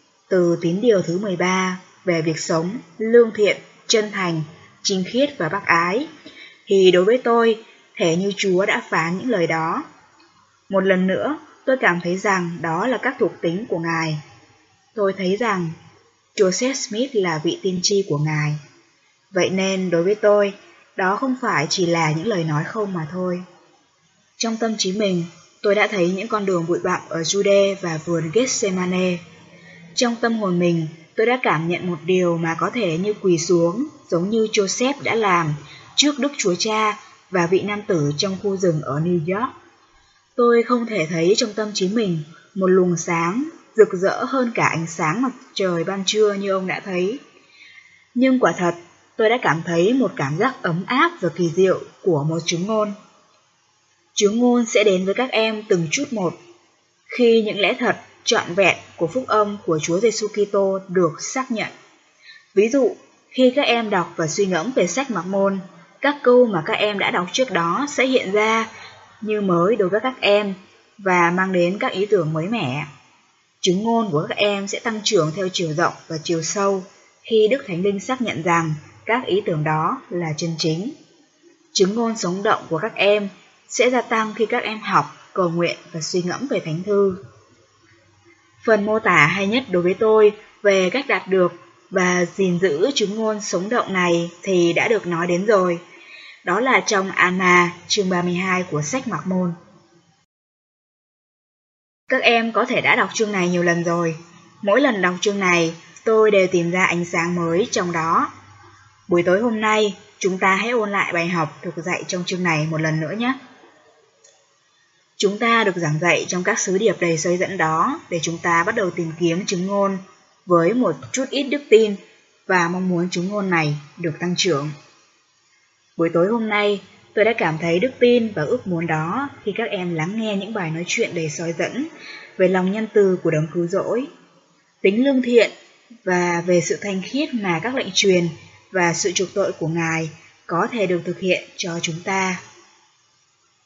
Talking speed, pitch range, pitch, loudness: 190 wpm, 170-215 Hz, 190 Hz, -20 LUFS